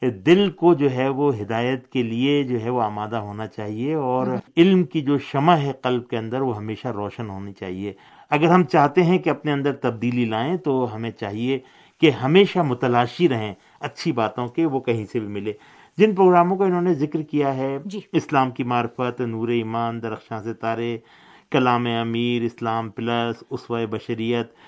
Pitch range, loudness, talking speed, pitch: 115-150 Hz, -22 LUFS, 180 wpm, 125 Hz